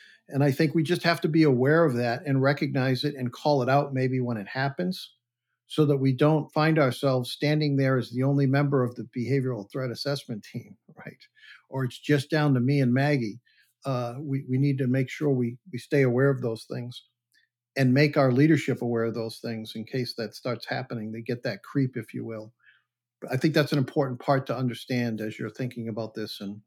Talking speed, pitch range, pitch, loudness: 220 wpm, 120-145 Hz, 130 Hz, -26 LUFS